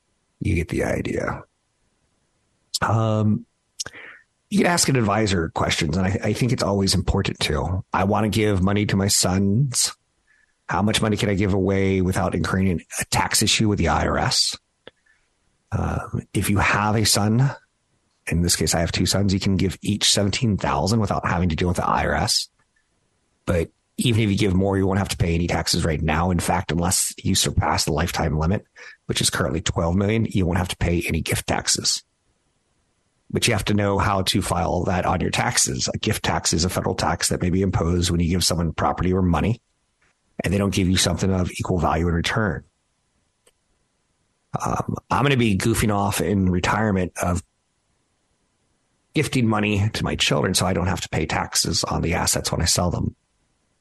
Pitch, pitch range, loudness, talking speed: 95 Hz, 90-105 Hz, -21 LUFS, 195 wpm